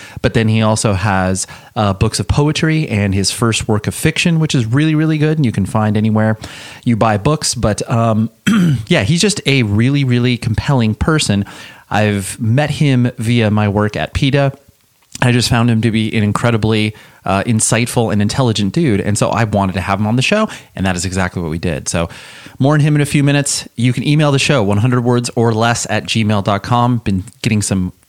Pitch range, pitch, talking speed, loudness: 105-135 Hz, 115 Hz, 210 wpm, -14 LUFS